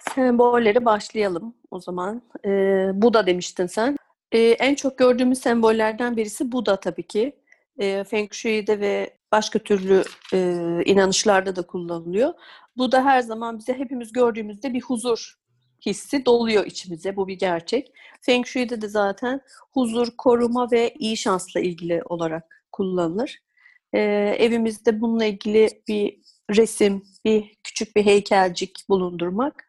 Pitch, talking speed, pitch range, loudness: 220 Hz, 135 wpm, 195-245 Hz, -22 LUFS